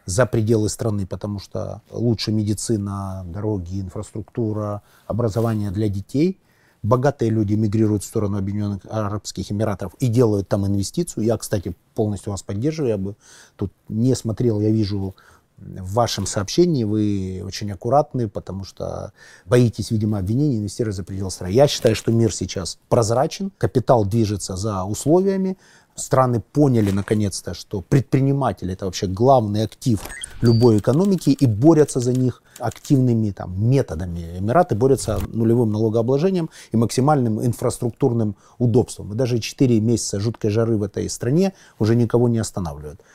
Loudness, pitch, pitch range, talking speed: -21 LUFS, 110 Hz, 100-125 Hz, 140 wpm